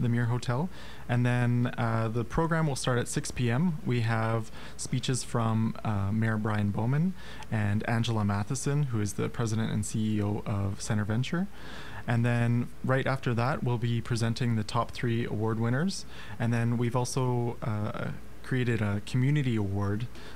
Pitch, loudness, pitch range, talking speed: 120 Hz, -30 LUFS, 110-130 Hz, 160 wpm